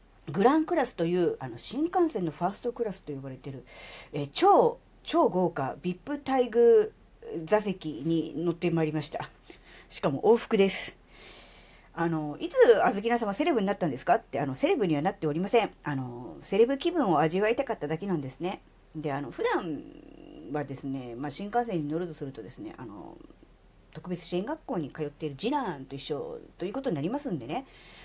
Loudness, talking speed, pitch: -29 LUFS, 370 characters per minute, 180 Hz